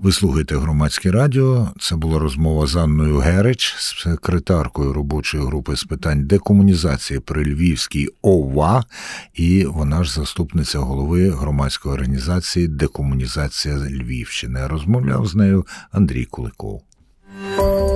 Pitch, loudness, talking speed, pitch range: 80 Hz, -18 LUFS, 105 wpm, 70-95 Hz